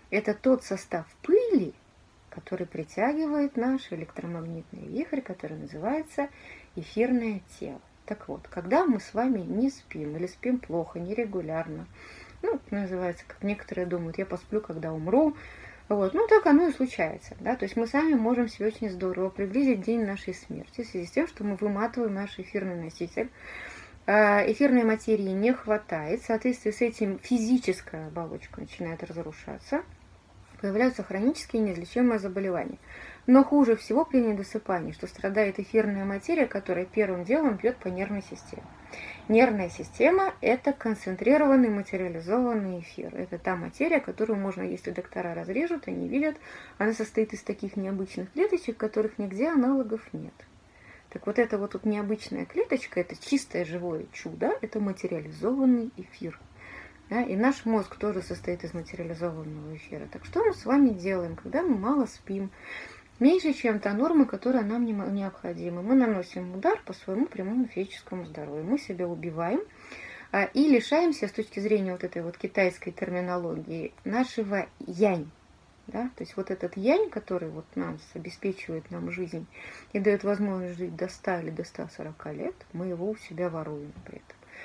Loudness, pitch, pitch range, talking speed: -28 LUFS, 210 Hz, 180-245 Hz, 150 wpm